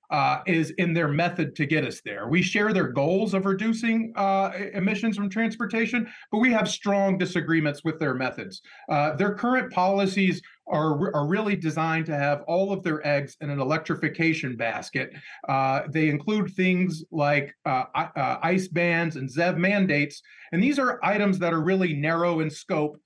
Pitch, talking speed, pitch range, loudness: 175 Hz, 175 wpm, 155-200 Hz, -25 LUFS